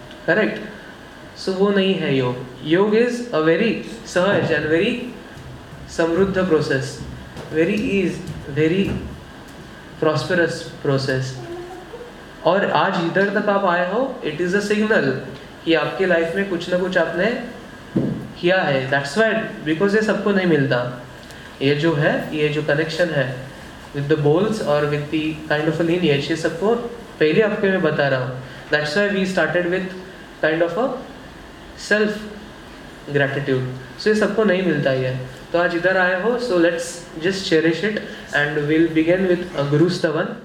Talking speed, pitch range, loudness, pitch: 155 wpm, 150-195 Hz, -20 LUFS, 170 Hz